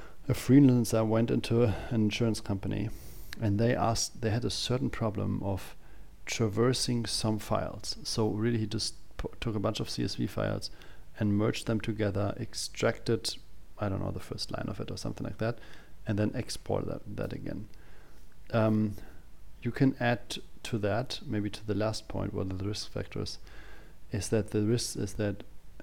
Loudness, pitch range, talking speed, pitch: -31 LUFS, 100-115 Hz, 170 wpm, 110 Hz